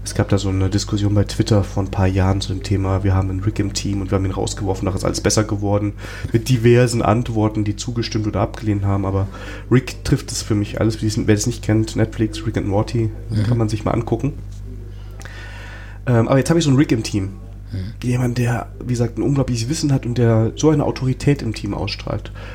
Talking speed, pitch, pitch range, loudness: 225 wpm, 105 Hz, 100-115 Hz, -19 LUFS